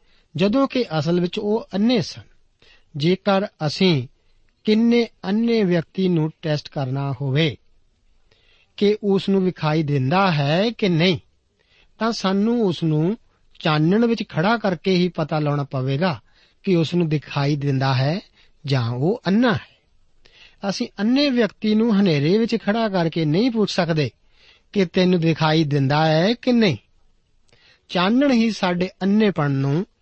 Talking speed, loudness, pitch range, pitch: 140 wpm, -20 LUFS, 145-210 Hz, 175 Hz